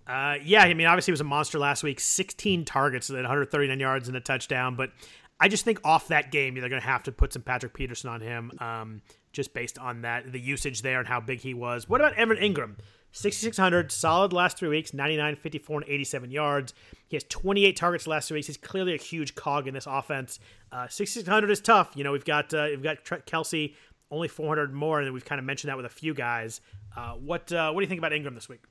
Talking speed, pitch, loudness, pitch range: 240 wpm, 145 Hz, -27 LUFS, 130-160 Hz